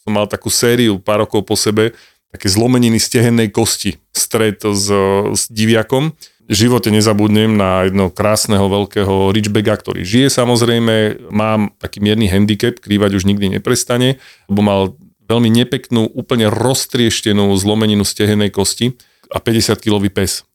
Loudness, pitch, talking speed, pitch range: -14 LUFS, 105 Hz, 135 wpm, 100-115 Hz